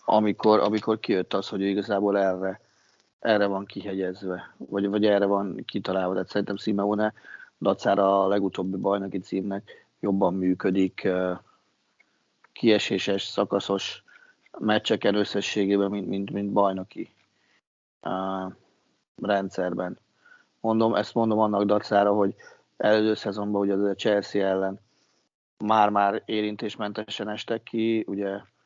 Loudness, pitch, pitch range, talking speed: -26 LUFS, 100 Hz, 95-105 Hz, 115 wpm